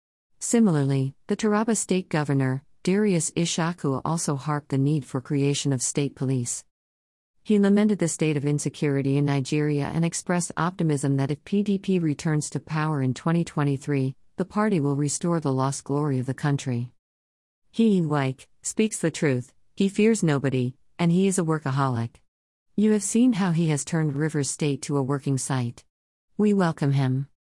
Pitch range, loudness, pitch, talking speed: 135-170 Hz, -25 LUFS, 145 Hz, 160 wpm